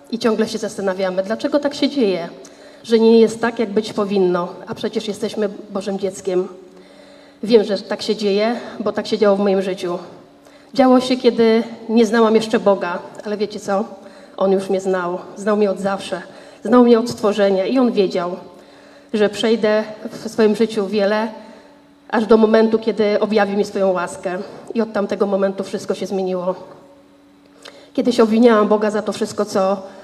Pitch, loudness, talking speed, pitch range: 210 Hz, -18 LUFS, 170 wpm, 195-225 Hz